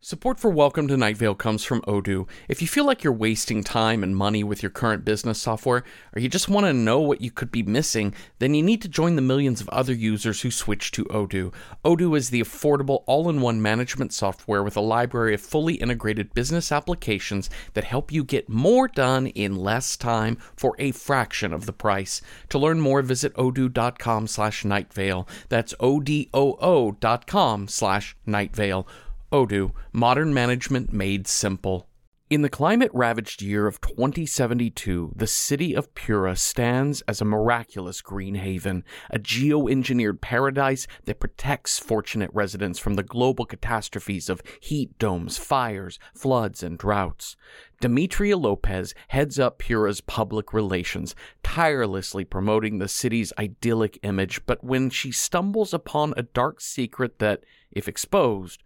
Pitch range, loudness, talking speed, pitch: 100-135 Hz, -24 LUFS, 155 wpm, 115 Hz